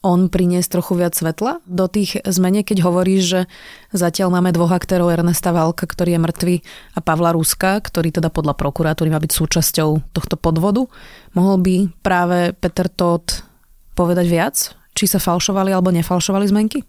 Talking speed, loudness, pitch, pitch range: 160 wpm, -17 LUFS, 180 Hz, 170-190 Hz